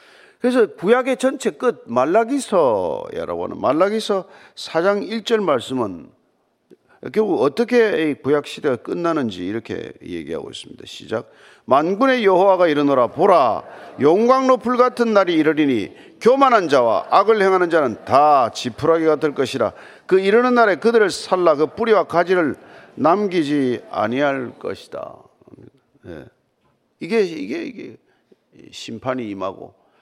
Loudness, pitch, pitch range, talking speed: -18 LUFS, 205 Hz, 160-250 Hz, 280 characters per minute